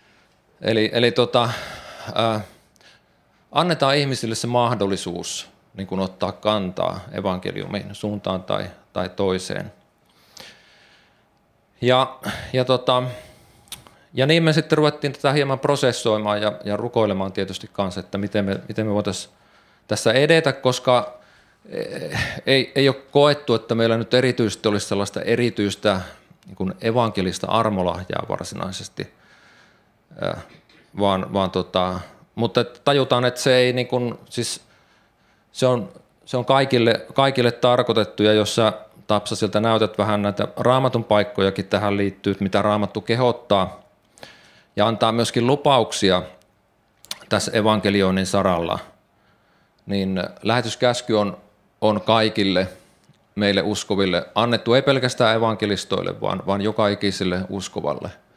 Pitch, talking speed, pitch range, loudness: 110 Hz, 115 wpm, 100-125 Hz, -21 LUFS